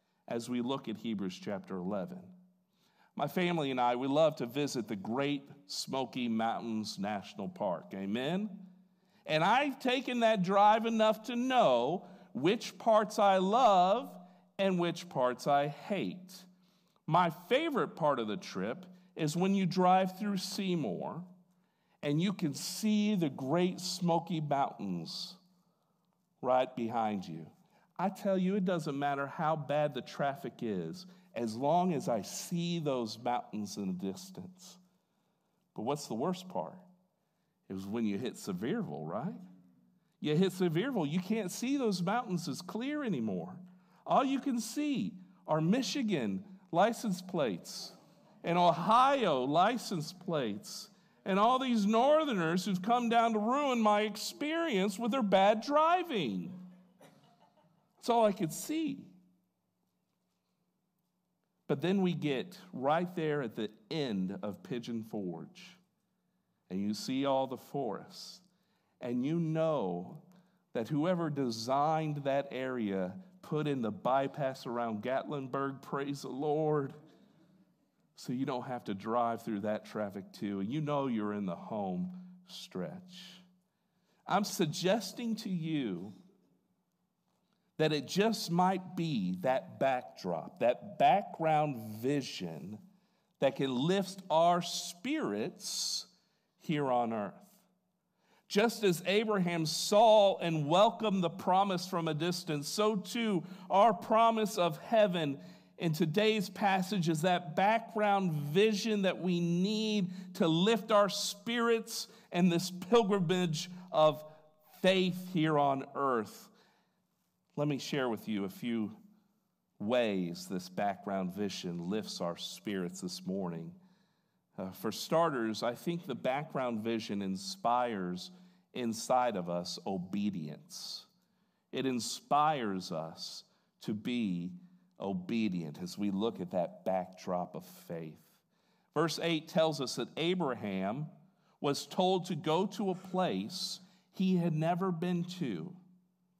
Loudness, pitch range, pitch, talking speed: -33 LUFS, 140-195 Hz, 180 Hz, 130 wpm